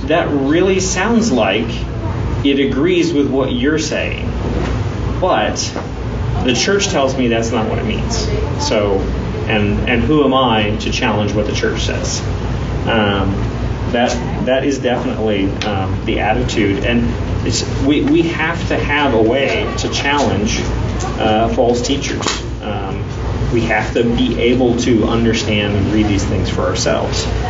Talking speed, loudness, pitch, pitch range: 150 wpm, -16 LUFS, 115 Hz, 105-125 Hz